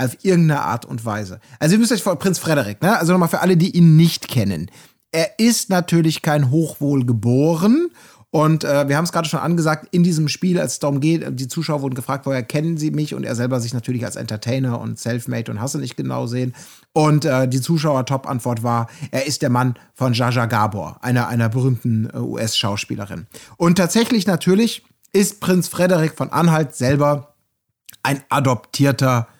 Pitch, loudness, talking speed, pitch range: 145 Hz, -18 LUFS, 190 wpm, 125-165 Hz